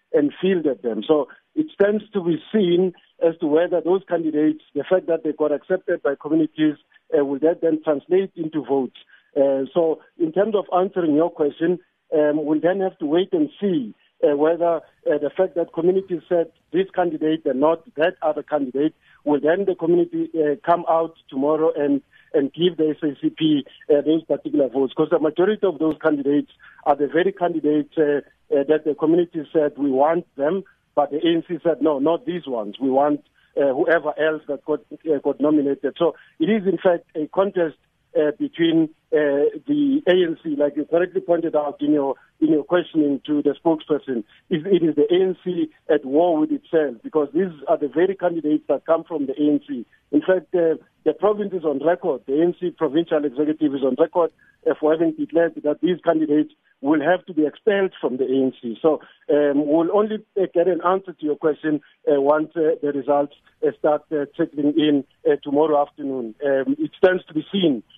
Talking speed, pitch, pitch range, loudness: 195 wpm, 160 Hz, 150-180 Hz, -21 LUFS